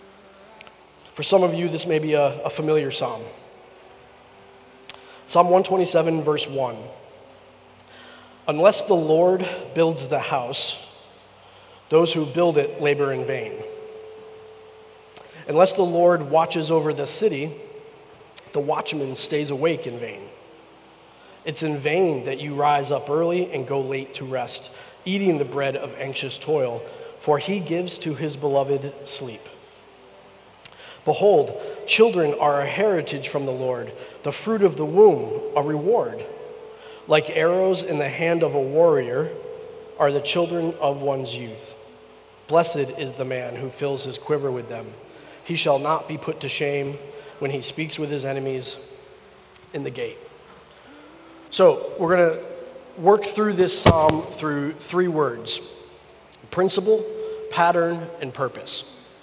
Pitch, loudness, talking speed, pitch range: 160 Hz, -22 LUFS, 140 wpm, 140-205 Hz